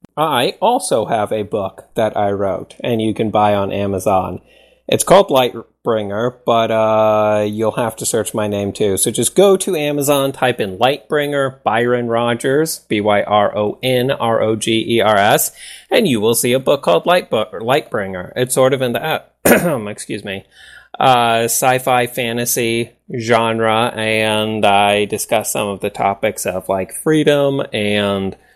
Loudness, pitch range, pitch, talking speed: -16 LUFS, 105-130 Hz, 115 Hz, 165 wpm